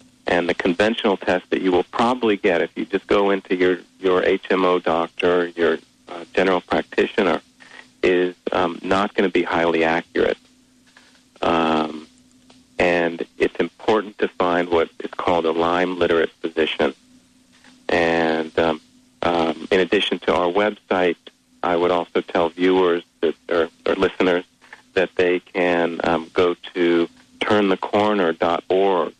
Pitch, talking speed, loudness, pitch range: 90 Hz, 140 wpm, -20 LUFS, 85-105 Hz